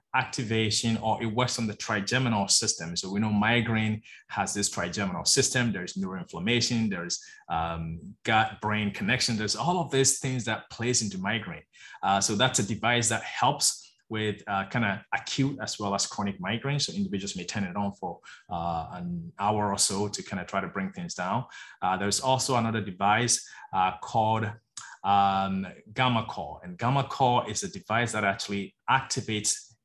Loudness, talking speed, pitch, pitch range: -27 LUFS, 175 wpm, 110 Hz, 100-120 Hz